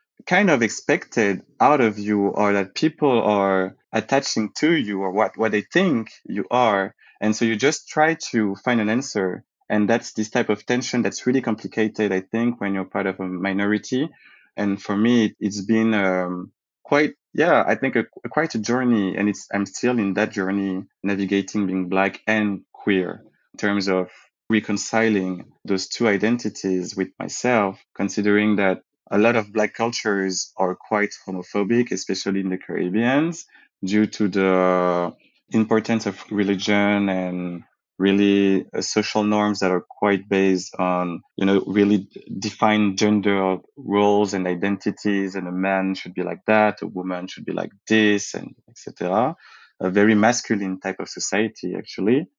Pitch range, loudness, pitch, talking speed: 95-110 Hz, -21 LUFS, 100 Hz, 160 wpm